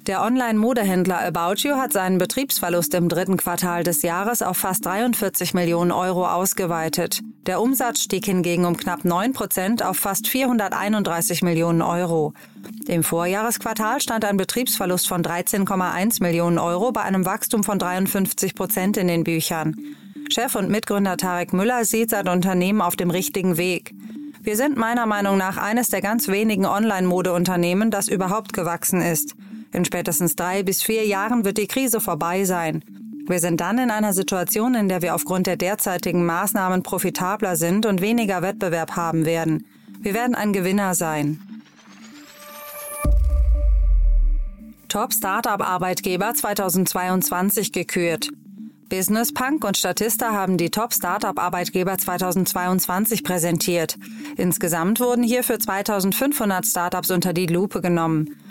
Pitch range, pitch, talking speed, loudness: 175-220 Hz, 190 Hz, 140 wpm, -21 LUFS